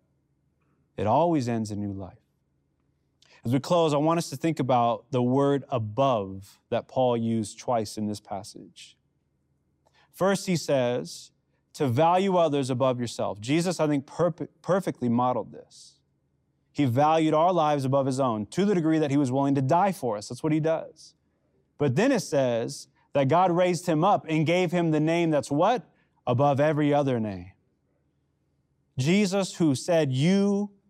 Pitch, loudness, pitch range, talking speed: 140 Hz, -25 LUFS, 120-165 Hz, 165 wpm